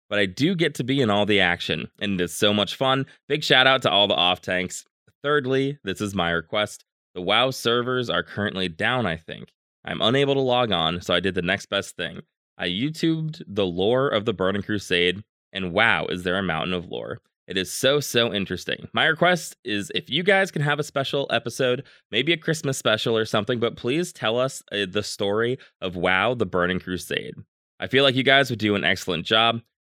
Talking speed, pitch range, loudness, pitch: 215 wpm, 95-135 Hz, -23 LUFS, 110 Hz